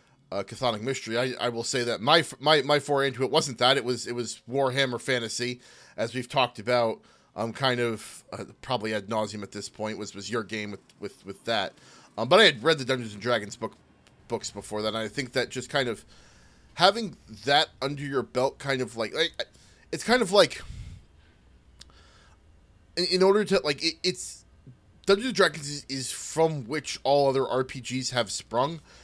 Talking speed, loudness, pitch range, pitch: 195 wpm, -26 LUFS, 110-140 Hz, 125 Hz